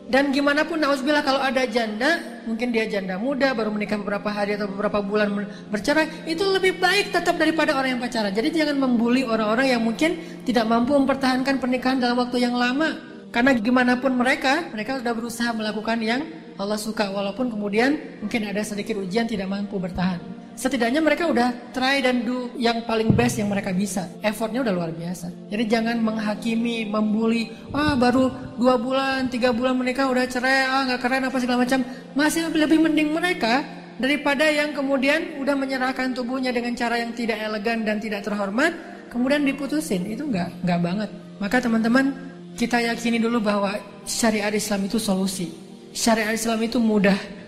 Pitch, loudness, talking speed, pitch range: 240 Hz, -22 LUFS, 170 wpm, 210-265 Hz